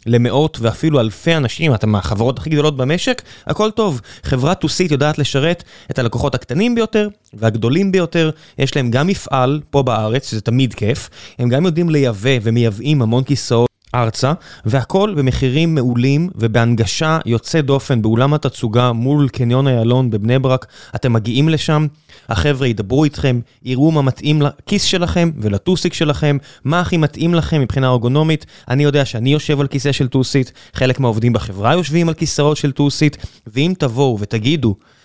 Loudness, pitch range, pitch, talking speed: -16 LUFS, 120-155 Hz, 135 Hz, 150 wpm